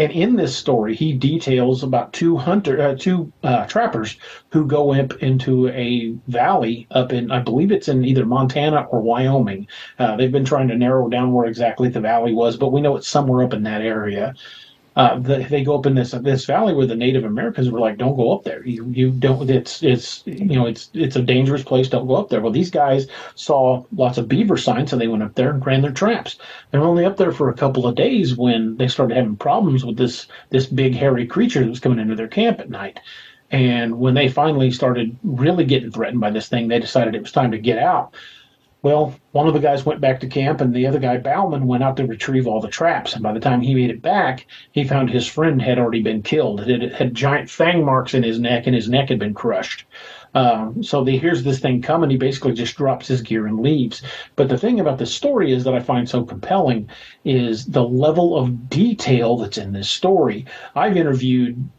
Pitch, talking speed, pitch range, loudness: 130 Hz, 235 wpm, 120-140 Hz, -18 LUFS